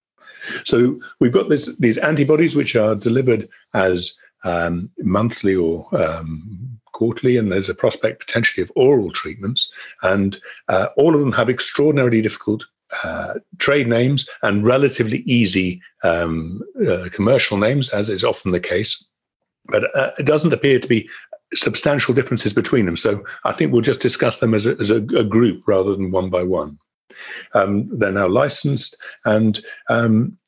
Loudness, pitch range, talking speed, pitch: -18 LUFS, 95-140 Hz, 160 wpm, 115 Hz